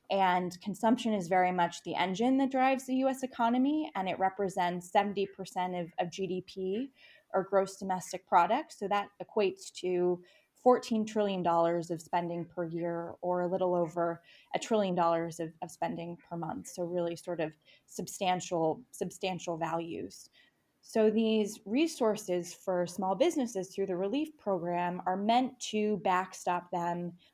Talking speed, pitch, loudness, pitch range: 145 wpm, 185 Hz, -32 LUFS, 175-215 Hz